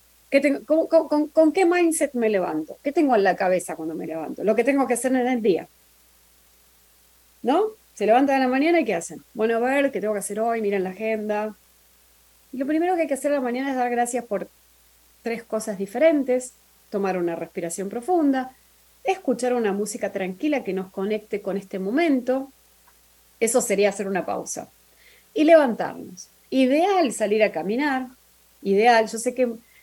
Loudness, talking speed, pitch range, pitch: -23 LUFS, 180 wpm, 195-275 Hz, 230 Hz